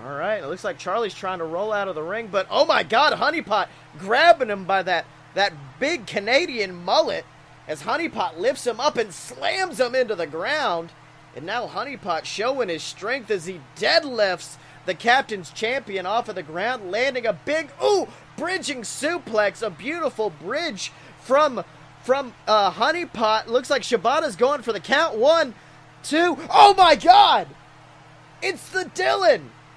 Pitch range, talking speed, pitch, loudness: 190-305 Hz, 160 wpm, 230 Hz, -22 LUFS